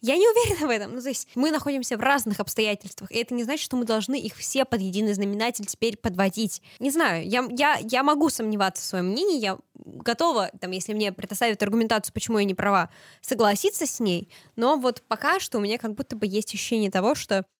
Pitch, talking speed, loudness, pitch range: 225 Hz, 215 wpm, -25 LUFS, 205-265 Hz